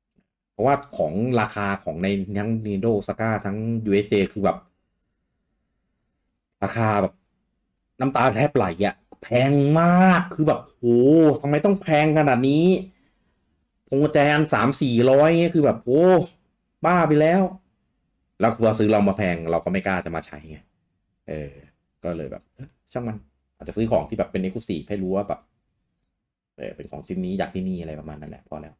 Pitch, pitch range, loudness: 110 Hz, 95-150 Hz, -21 LUFS